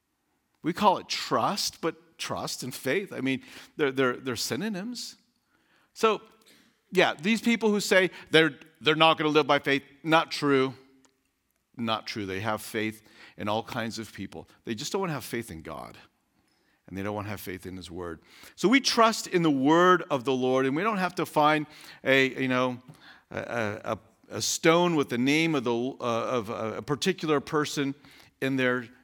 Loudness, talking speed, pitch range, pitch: -26 LUFS, 190 wpm, 115-160 Hz, 135 Hz